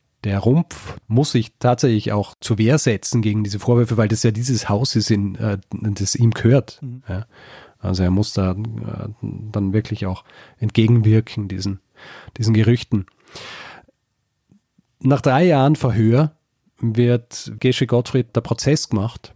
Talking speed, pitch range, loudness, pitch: 130 wpm, 105-125 Hz, -19 LUFS, 115 Hz